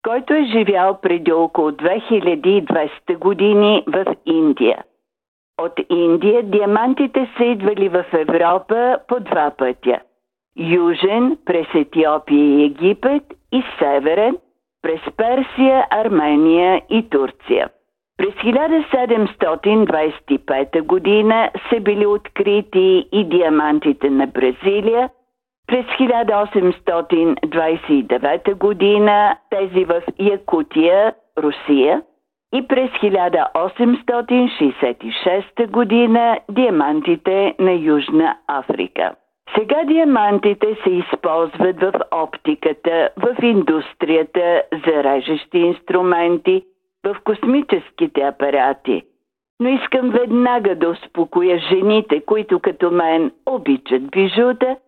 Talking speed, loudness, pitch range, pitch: 90 wpm, -16 LUFS, 165-240 Hz, 200 Hz